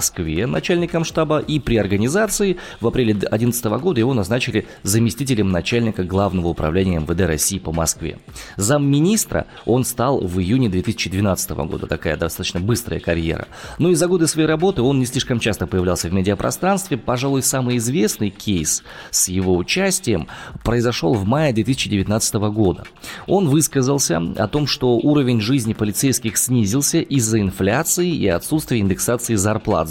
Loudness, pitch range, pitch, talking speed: -19 LUFS, 95-140 Hz, 115 Hz, 145 wpm